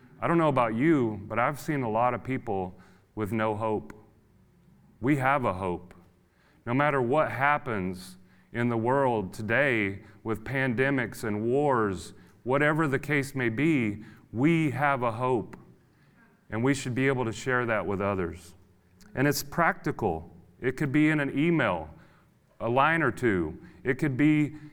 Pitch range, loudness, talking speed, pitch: 105-140 Hz, -27 LUFS, 160 wpm, 120 Hz